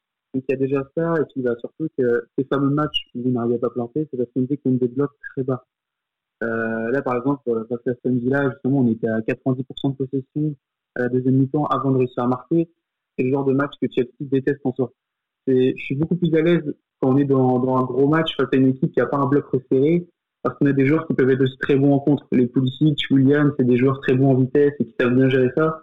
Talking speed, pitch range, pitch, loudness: 270 wpm, 125-145 Hz, 135 Hz, -21 LUFS